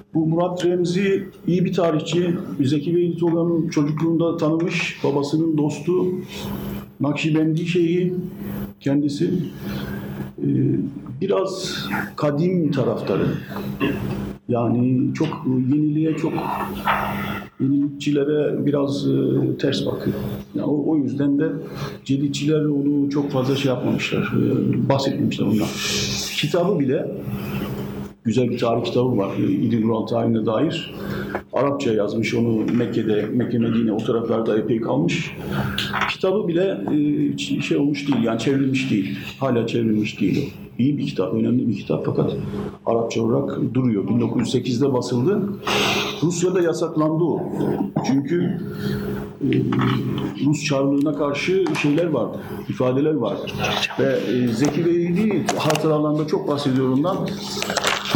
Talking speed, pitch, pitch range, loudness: 105 wpm, 145 Hz, 115-165 Hz, -21 LUFS